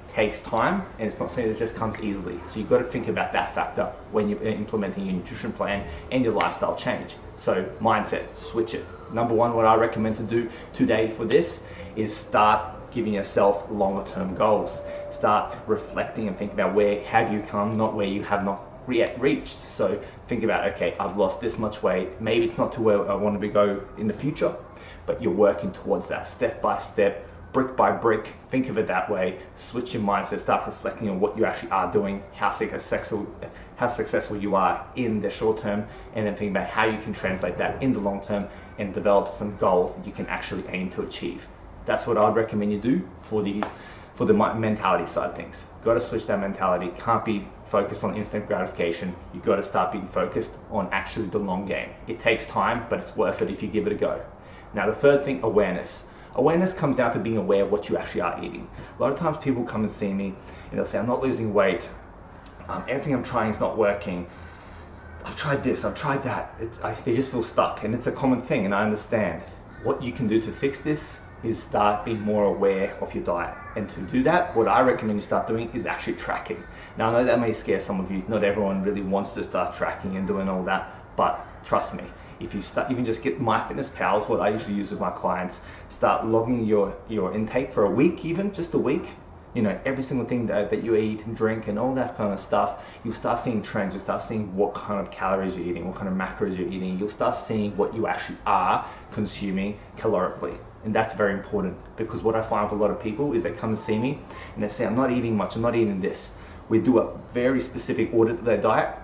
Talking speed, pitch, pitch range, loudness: 230 wpm, 105 Hz, 100-115 Hz, -25 LUFS